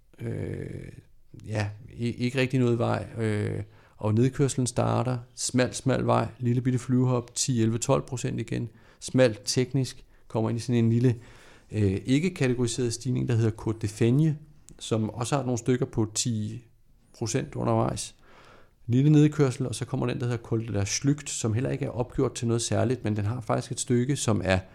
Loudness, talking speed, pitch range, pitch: -27 LUFS, 170 wpm, 115-130 Hz, 120 Hz